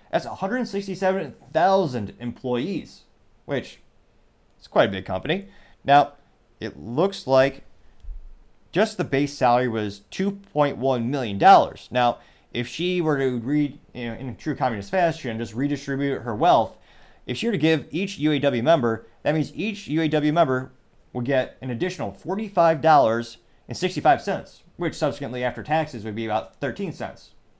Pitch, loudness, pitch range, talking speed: 135 Hz, -23 LUFS, 115-160 Hz, 140 wpm